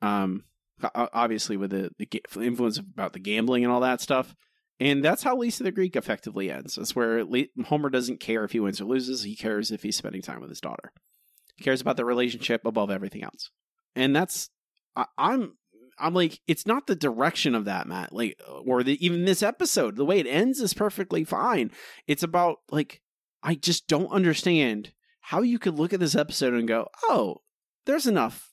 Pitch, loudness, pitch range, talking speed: 140 Hz, -26 LUFS, 115-185 Hz, 200 wpm